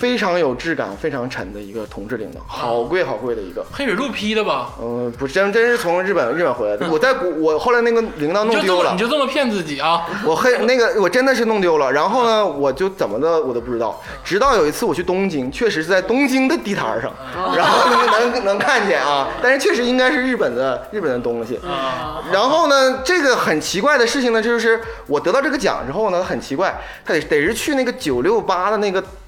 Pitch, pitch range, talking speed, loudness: 205 Hz, 160-250 Hz, 345 characters per minute, -17 LUFS